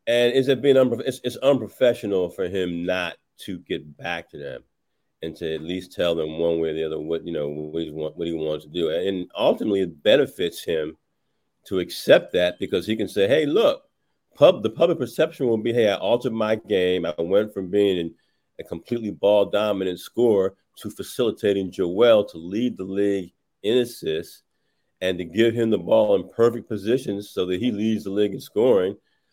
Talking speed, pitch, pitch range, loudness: 205 wpm, 100 Hz, 85-115 Hz, -23 LUFS